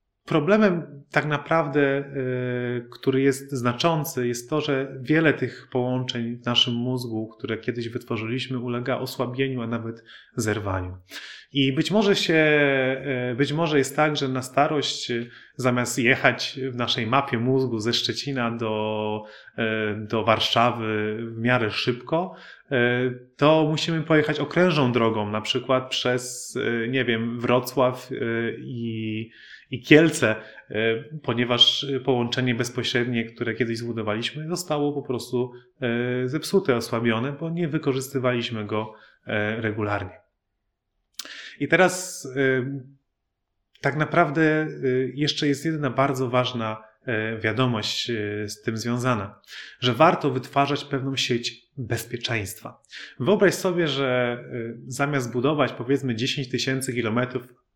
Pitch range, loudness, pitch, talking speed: 115-140 Hz, -24 LUFS, 125 Hz, 110 wpm